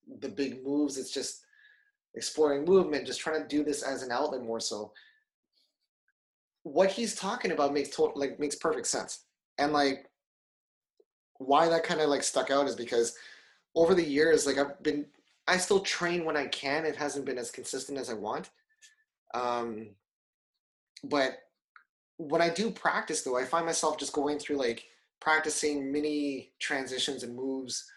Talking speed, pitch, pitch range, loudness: 165 wpm, 150 Hz, 135-170 Hz, -30 LUFS